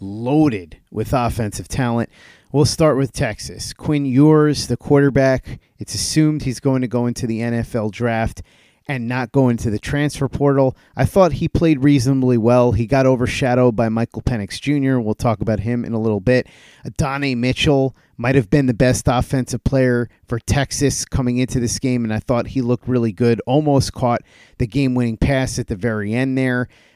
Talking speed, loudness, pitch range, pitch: 185 wpm, -18 LUFS, 115-135 Hz, 125 Hz